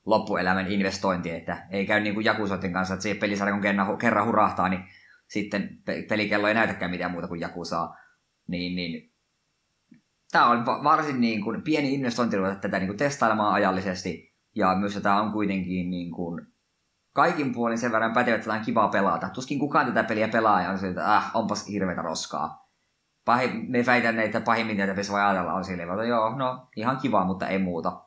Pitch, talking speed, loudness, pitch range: 100 Hz, 185 wpm, -25 LUFS, 95-110 Hz